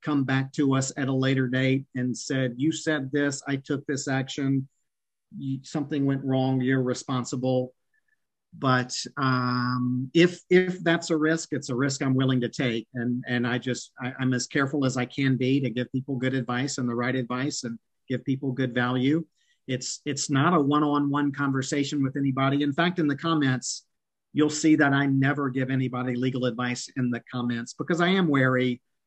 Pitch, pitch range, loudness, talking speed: 135 Hz, 125-145 Hz, -26 LUFS, 190 wpm